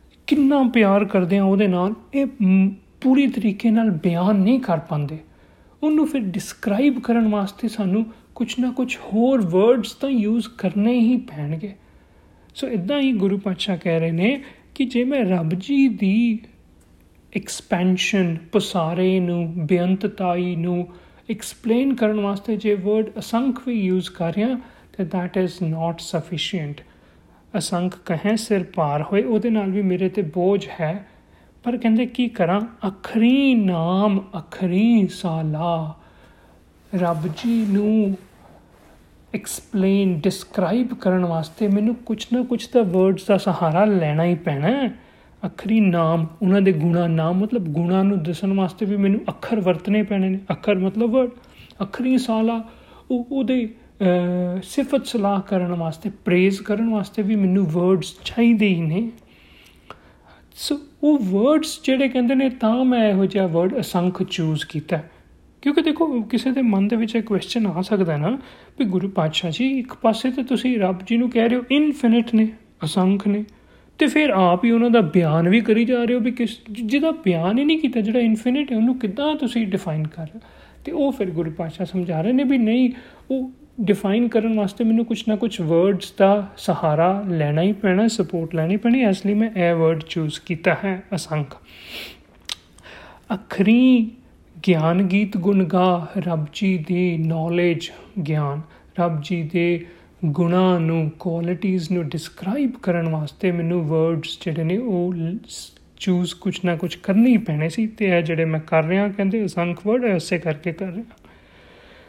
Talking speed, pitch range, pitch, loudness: 150 wpm, 175-230 Hz, 200 Hz, -20 LUFS